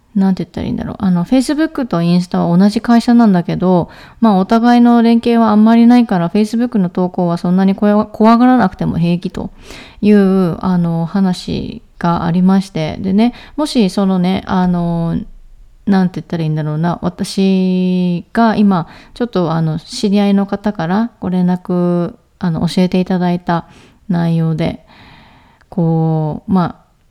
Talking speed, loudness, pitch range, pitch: 350 characters per minute, -14 LUFS, 175-215 Hz, 190 Hz